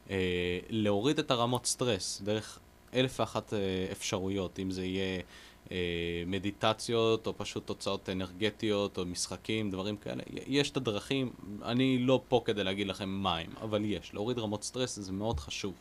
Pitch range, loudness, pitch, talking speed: 95-115 Hz, -33 LUFS, 100 Hz, 160 wpm